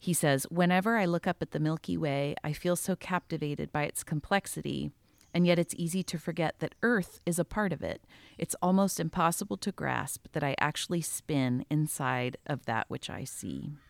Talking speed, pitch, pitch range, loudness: 195 wpm, 170 Hz, 150-180 Hz, -31 LUFS